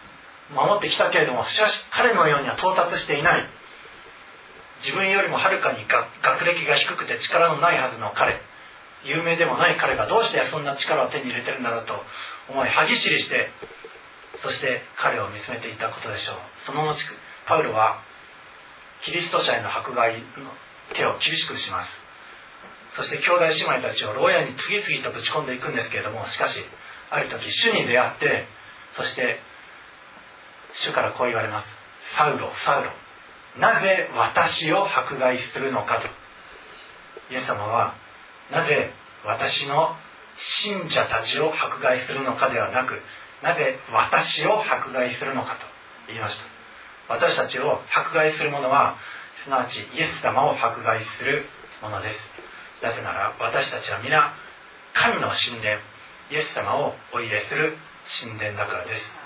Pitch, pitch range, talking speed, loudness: 140 Hz, 110-165 Hz, 300 characters per minute, -22 LUFS